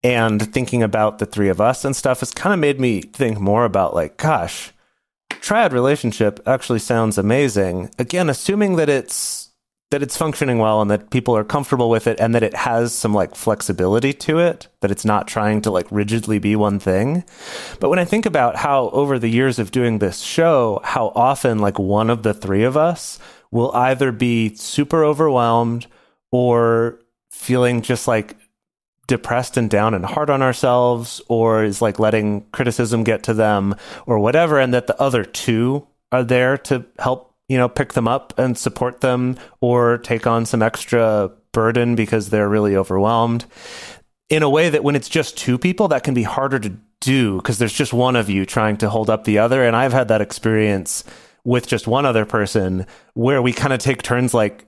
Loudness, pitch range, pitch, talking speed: -18 LUFS, 110-130 Hz, 120 Hz, 195 wpm